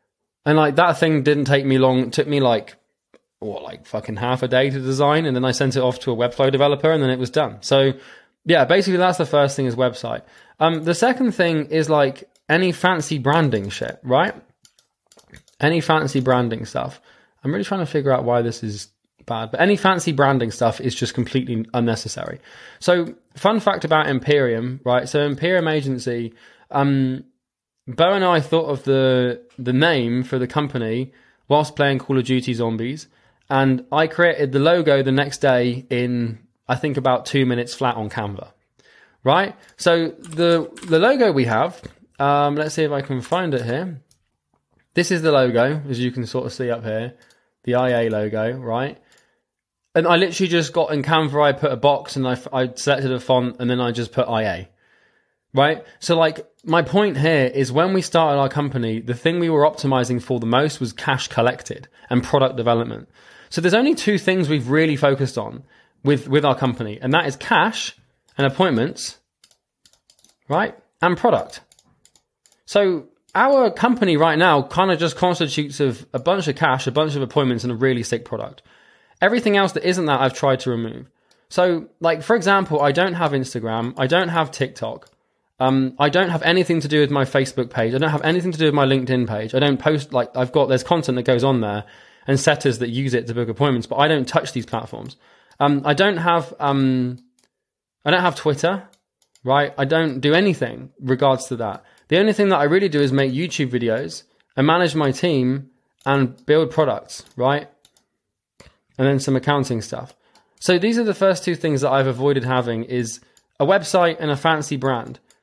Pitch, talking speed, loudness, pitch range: 140 Hz, 195 wpm, -19 LUFS, 125-160 Hz